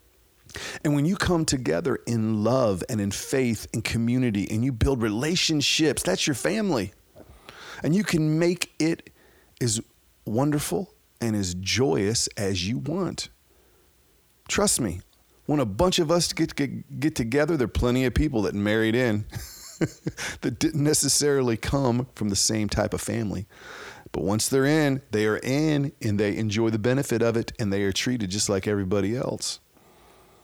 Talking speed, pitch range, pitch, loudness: 165 wpm, 105-145 Hz, 120 Hz, -25 LUFS